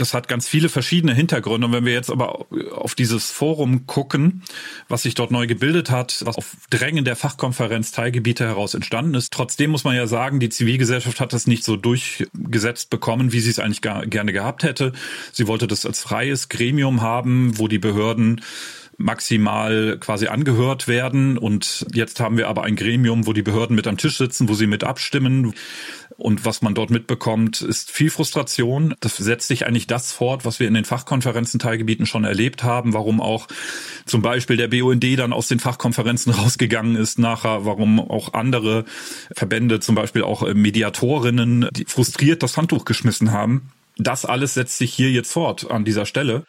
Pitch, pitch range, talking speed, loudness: 120 Hz, 115-130 Hz, 185 wpm, -20 LUFS